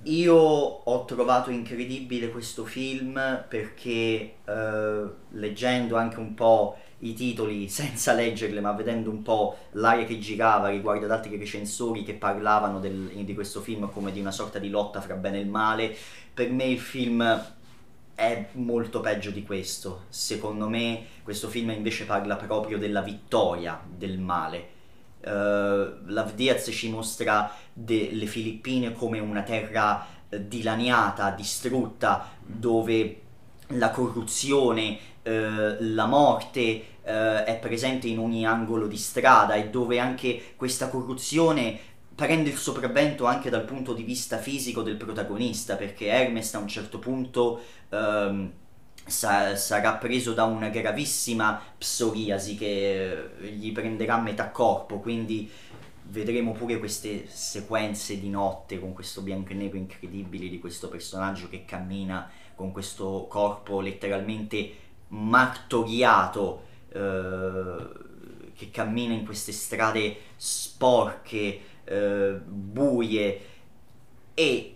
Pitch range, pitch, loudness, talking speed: 100-115 Hz, 110 Hz, -27 LUFS, 125 wpm